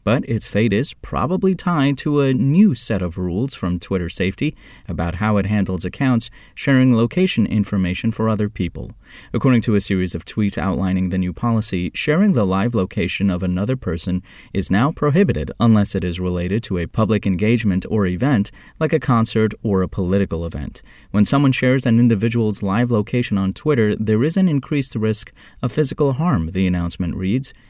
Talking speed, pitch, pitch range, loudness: 180 wpm, 110 Hz, 95-130 Hz, -19 LUFS